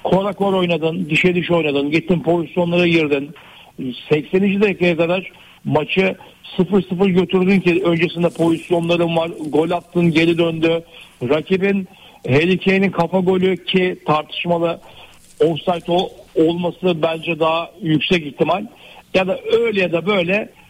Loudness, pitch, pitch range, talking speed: -17 LUFS, 175 Hz, 165-185 Hz, 120 wpm